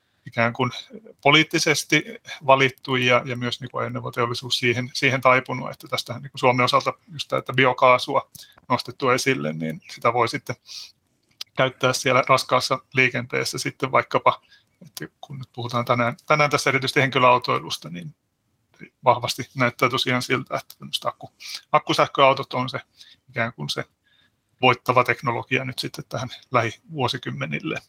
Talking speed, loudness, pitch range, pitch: 130 wpm, -22 LUFS, 125-135 Hz, 130 Hz